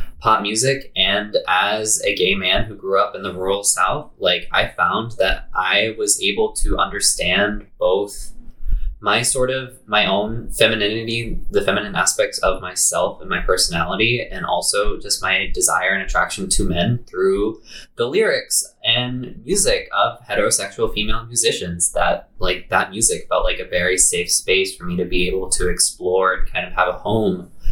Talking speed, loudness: 170 wpm, -18 LUFS